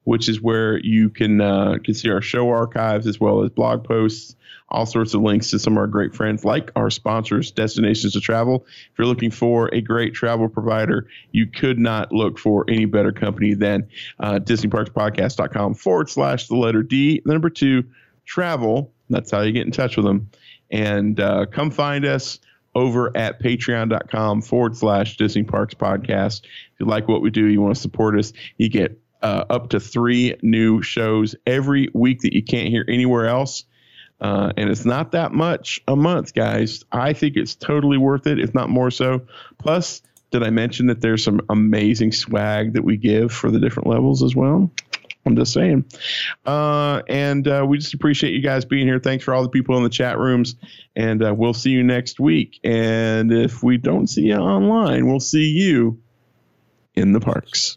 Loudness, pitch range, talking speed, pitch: -19 LUFS, 110-130 Hz, 195 wpm, 115 Hz